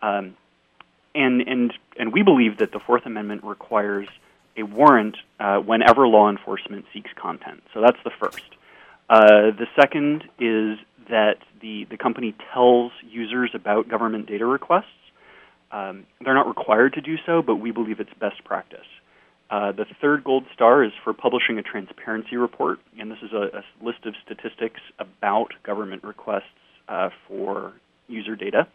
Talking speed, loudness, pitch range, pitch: 160 wpm, -21 LUFS, 105-125 Hz, 110 Hz